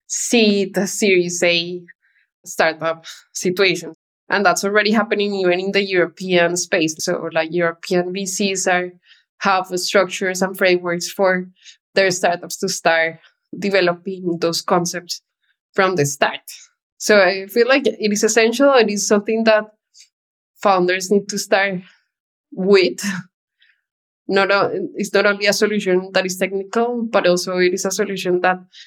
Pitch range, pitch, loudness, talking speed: 180-205 Hz, 190 Hz, -18 LUFS, 140 wpm